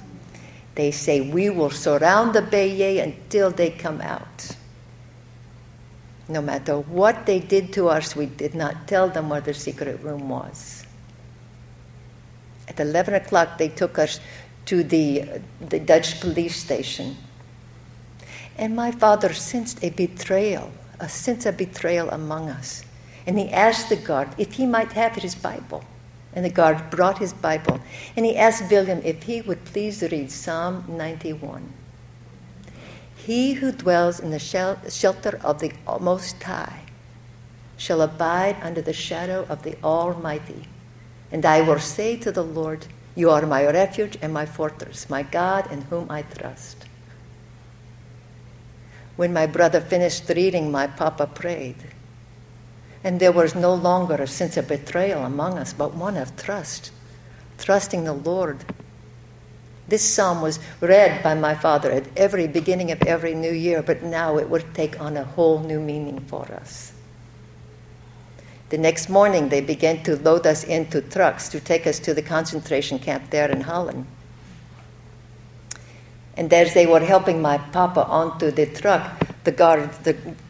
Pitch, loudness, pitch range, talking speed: 155 Hz, -22 LUFS, 125-175 Hz, 150 wpm